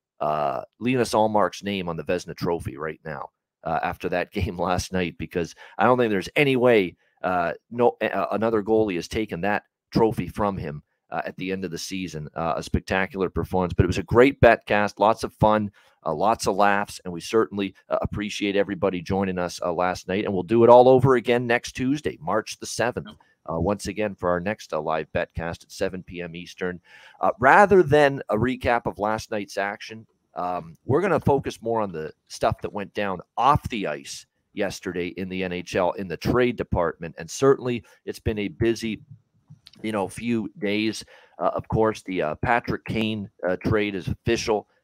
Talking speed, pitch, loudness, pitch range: 200 wpm, 105 Hz, -24 LUFS, 90-115 Hz